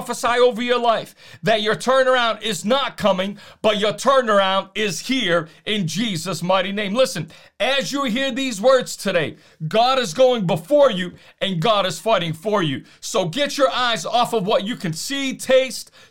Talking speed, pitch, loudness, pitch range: 180 wpm, 220 Hz, -19 LUFS, 190-255 Hz